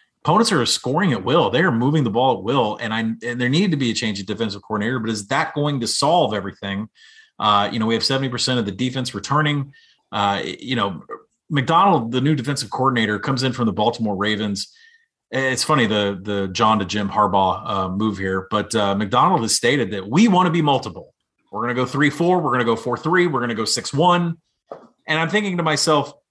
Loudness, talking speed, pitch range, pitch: -19 LUFS, 230 wpm, 105-145 Hz, 120 Hz